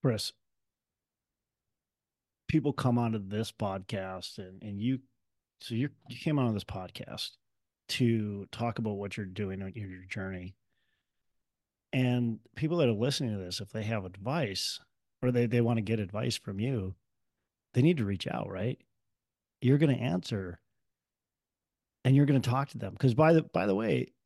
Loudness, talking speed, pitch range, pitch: -31 LUFS, 165 wpm, 100-125 Hz, 115 Hz